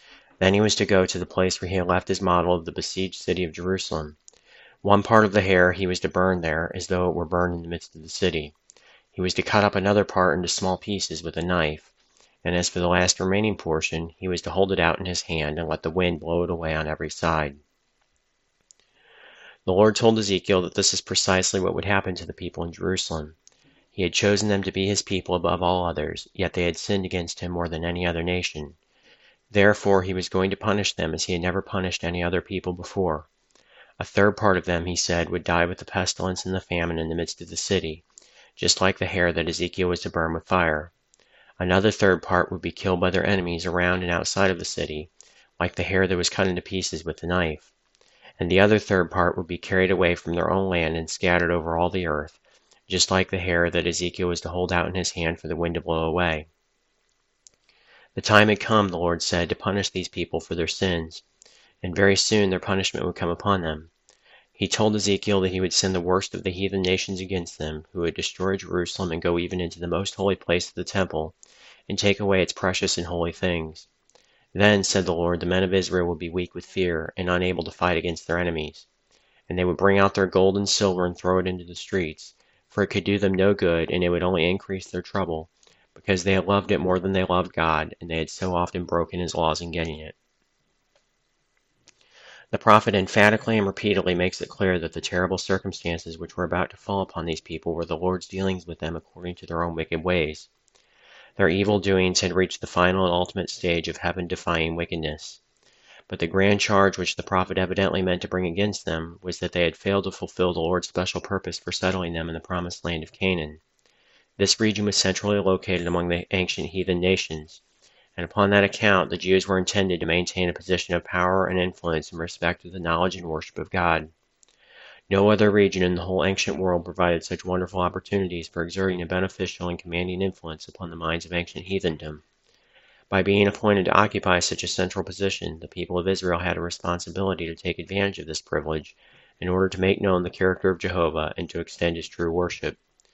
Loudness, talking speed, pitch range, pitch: -24 LUFS, 225 wpm, 85-95 Hz, 90 Hz